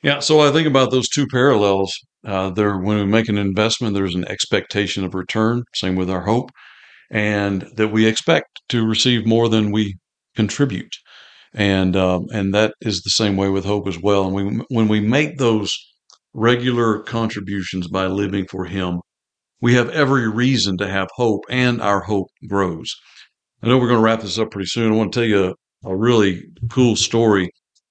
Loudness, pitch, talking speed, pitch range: -18 LUFS, 105 Hz, 190 wpm, 95-115 Hz